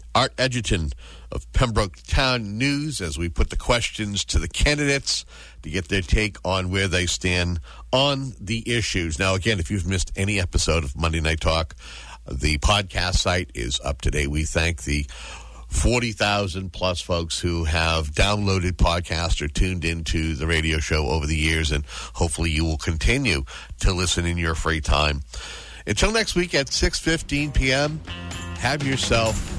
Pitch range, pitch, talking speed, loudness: 80-105 Hz, 90 Hz, 165 wpm, -23 LUFS